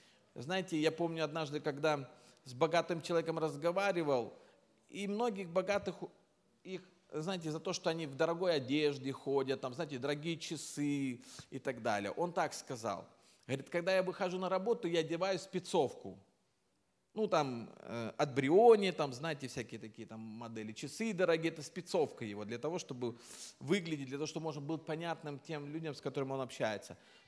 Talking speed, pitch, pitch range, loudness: 160 wpm, 155 Hz, 135-175 Hz, -37 LUFS